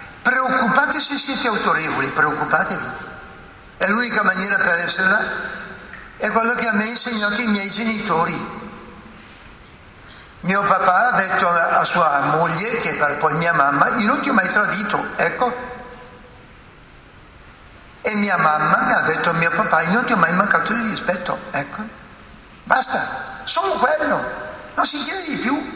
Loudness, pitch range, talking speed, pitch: -15 LUFS, 170-245 Hz, 150 wpm, 210 Hz